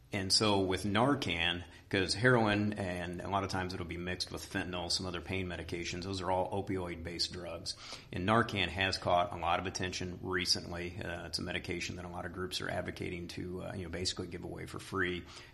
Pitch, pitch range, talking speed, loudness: 90 Hz, 90-100 Hz, 210 wpm, -35 LUFS